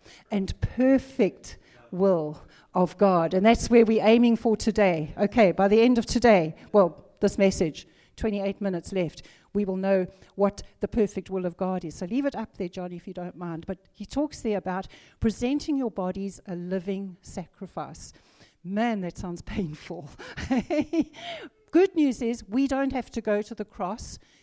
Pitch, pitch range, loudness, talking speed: 200 Hz, 185-230 Hz, -25 LUFS, 170 wpm